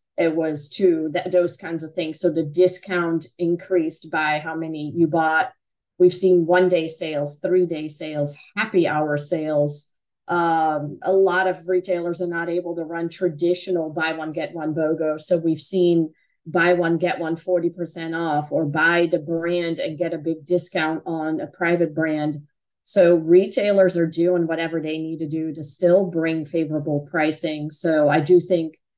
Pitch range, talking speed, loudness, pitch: 155-175 Hz, 175 wpm, -21 LUFS, 165 Hz